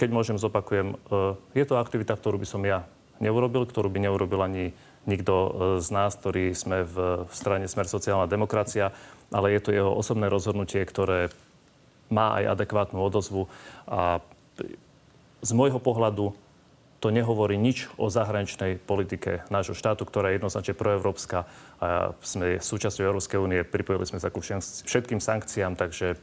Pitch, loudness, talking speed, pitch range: 100 Hz, -27 LUFS, 145 wpm, 95-110 Hz